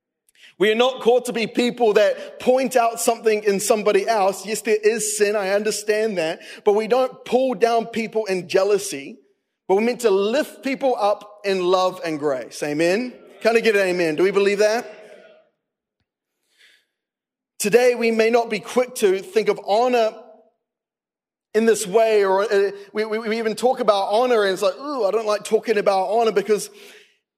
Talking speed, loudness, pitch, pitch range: 175 wpm, -20 LUFS, 215 Hz, 200-230 Hz